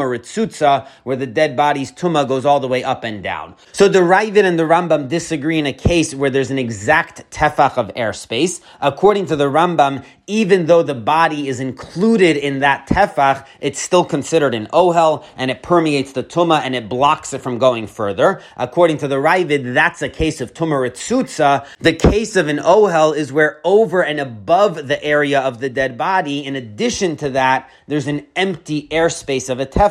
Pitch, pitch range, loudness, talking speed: 145 Hz, 135-170 Hz, -16 LUFS, 195 wpm